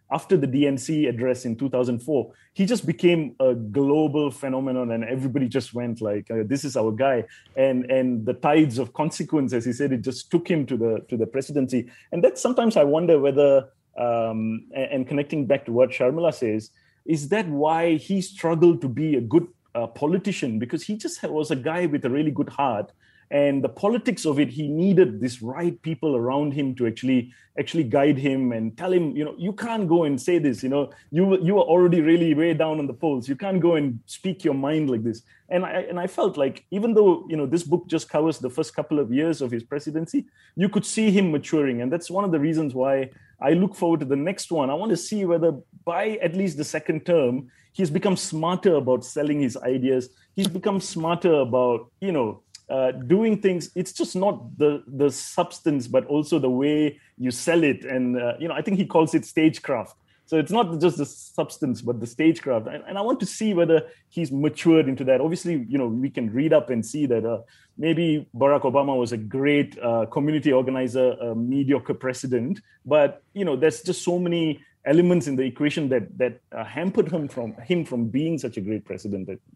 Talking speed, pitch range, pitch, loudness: 215 wpm, 130-170 Hz, 145 Hz, -23 LUFS